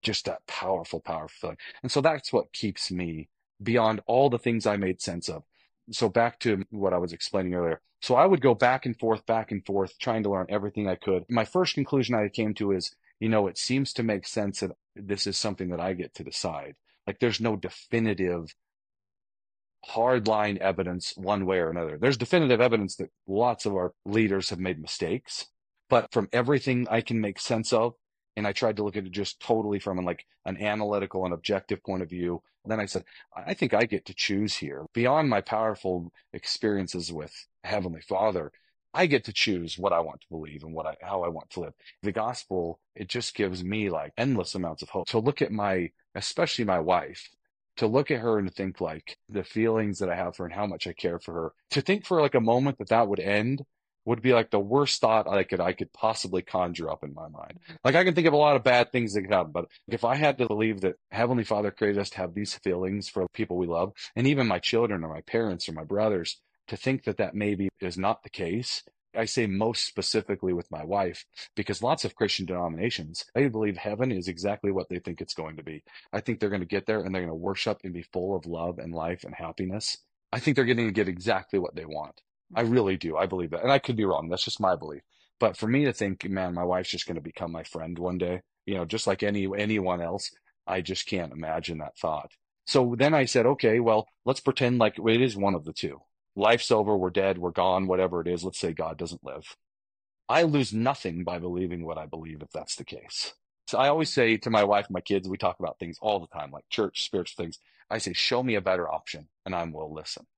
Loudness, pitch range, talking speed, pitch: -28 LUFS, 90-115 Hz, 235 wpm, 100 Hz